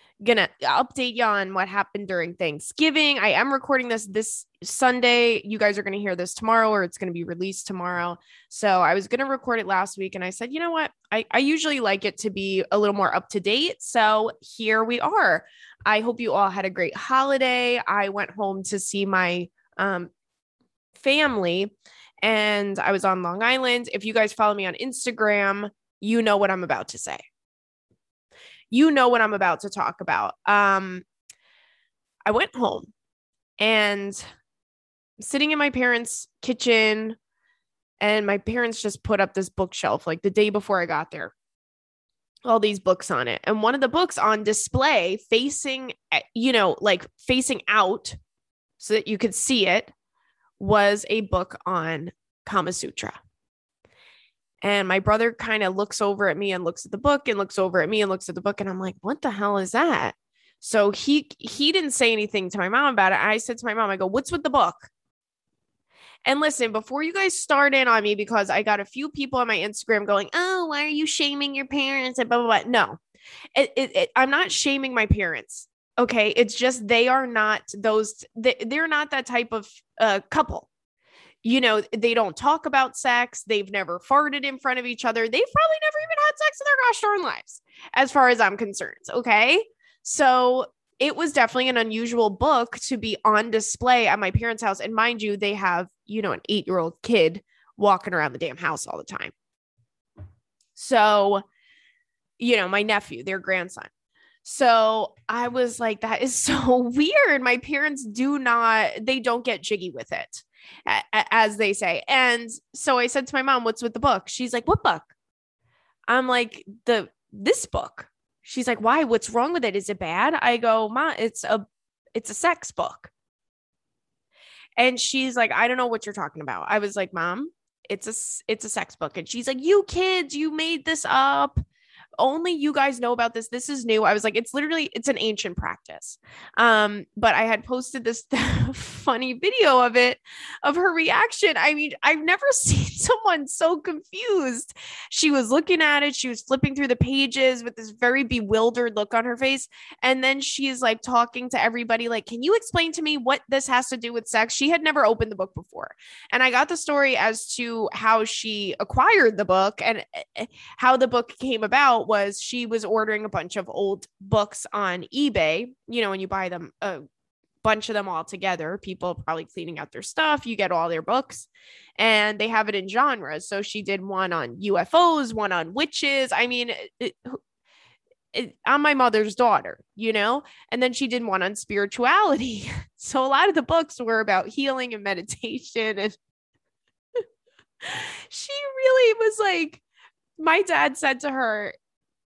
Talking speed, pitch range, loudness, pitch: 190 wpm, 205-270 Hz, -22 LUFS, 230 Hz